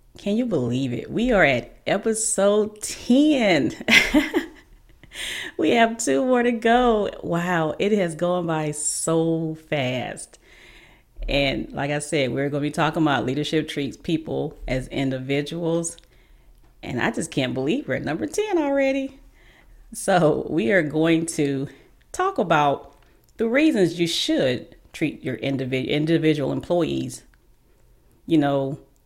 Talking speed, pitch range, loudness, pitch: 135 wpm, 140-215 Hz, -22 LUFS, 165 Hz